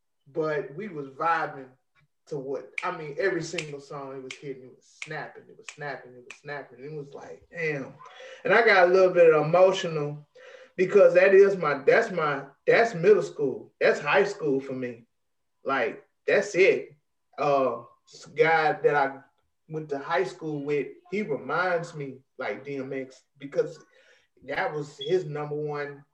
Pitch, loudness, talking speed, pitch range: 155 Hz, -25 LUFS, 165 wpm, 140-195 Hz